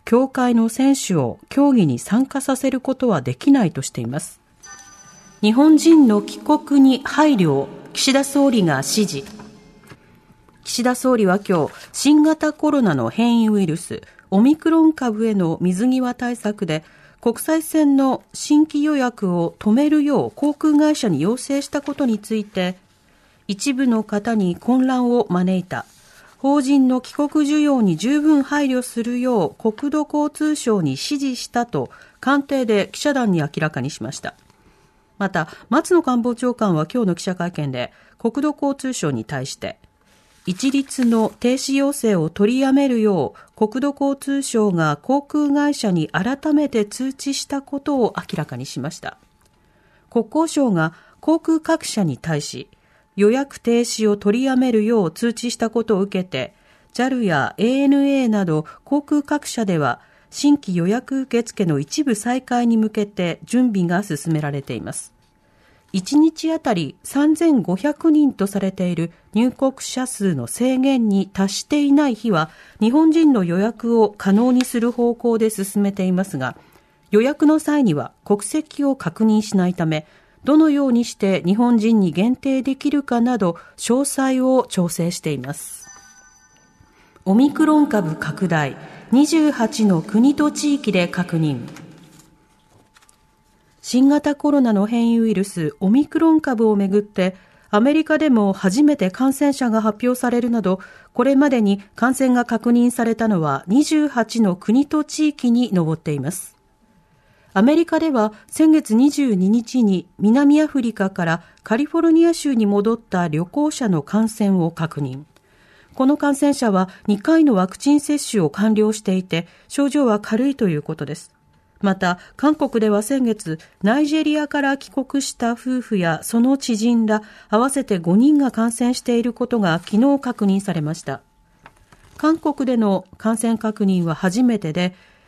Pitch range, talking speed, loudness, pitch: 190-275 Hz, 275 characters per minute, -19 LUFS, 230 Hz